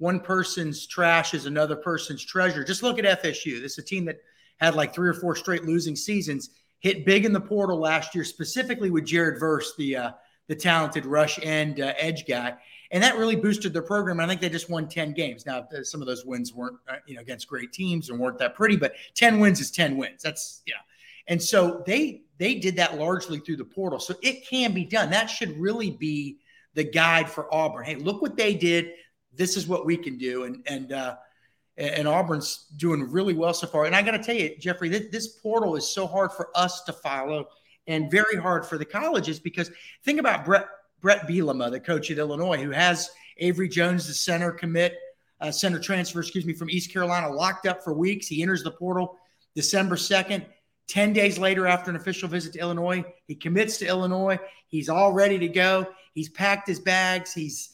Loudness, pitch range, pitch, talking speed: -25 LUFS, 155-190 Hz, 175 Hz, 215 wpm